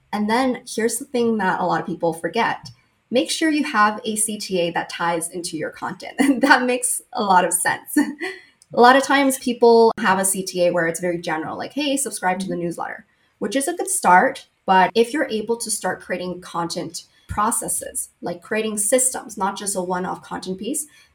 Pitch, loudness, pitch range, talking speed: 215 Hz, -20 LUFS, 180-255 Hz, 200 wpm